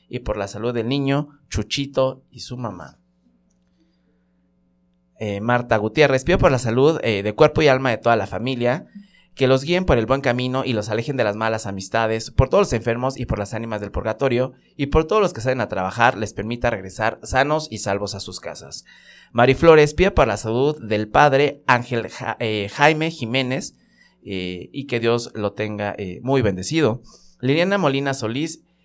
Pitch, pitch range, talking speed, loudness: 120 Hz, 105-140 Hz, 190 wpm, -20 LUFS